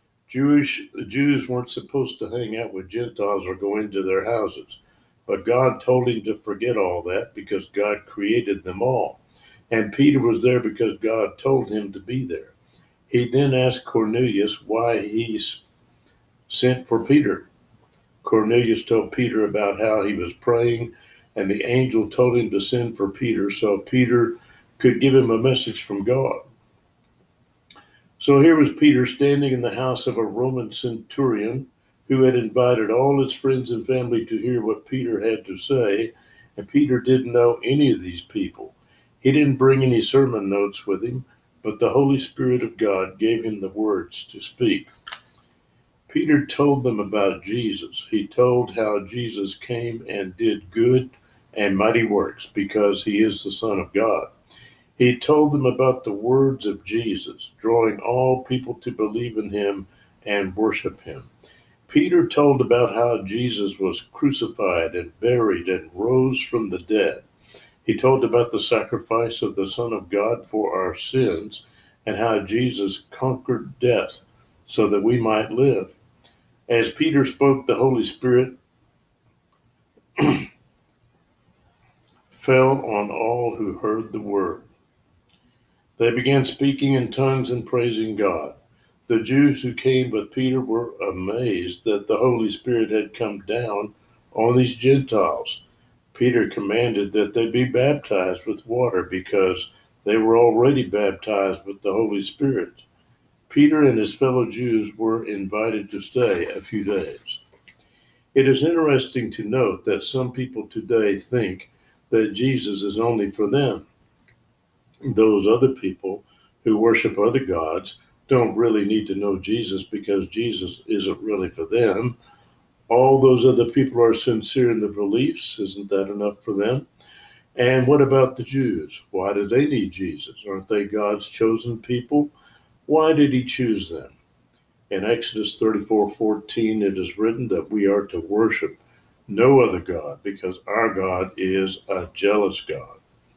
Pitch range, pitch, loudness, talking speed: 105-130 Hz, 115 Hz, -21 LUFS, 155 wpm